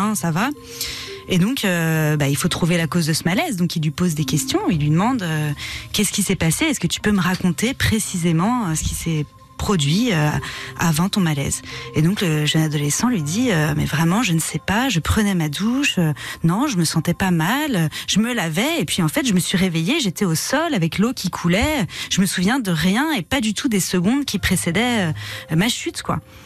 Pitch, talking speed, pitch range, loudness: 180 Hz, 230 wpm, 160-210 Hz, -19 LUFS